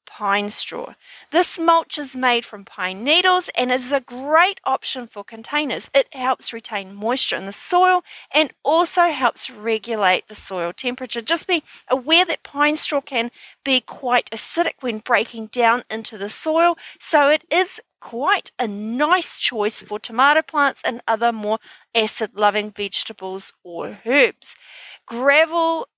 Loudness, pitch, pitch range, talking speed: -20 LUFS, 255 Hz, 220-310 Hz, 150 wpm